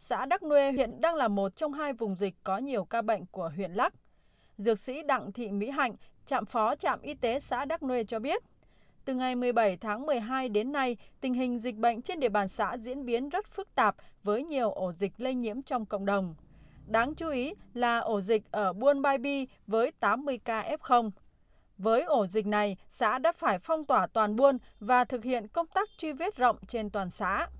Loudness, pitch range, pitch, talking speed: -30 LUFS, 210-275 Hz, 245 Hz, 215 wpm